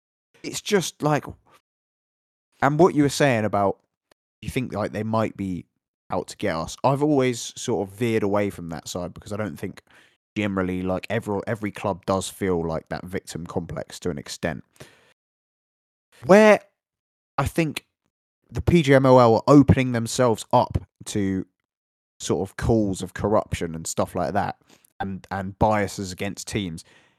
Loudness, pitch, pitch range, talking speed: -23 LUFS, 105 Hz, 95-125 Hz, 155 wpm